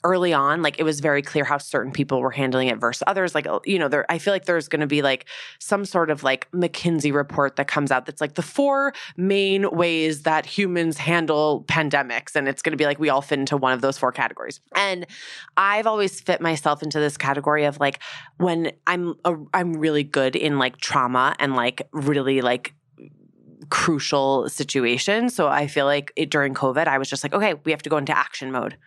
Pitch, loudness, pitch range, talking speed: 150 Hz, -22 LUFS, 140-170 Hz, 220 wpm